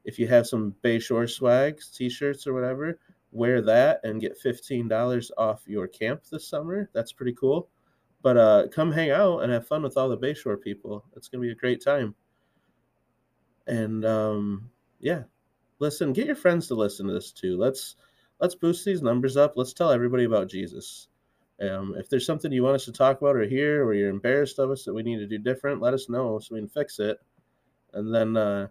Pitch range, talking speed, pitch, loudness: 110-145 Hz, 210 wpm, 125 Hz, -26 LUFS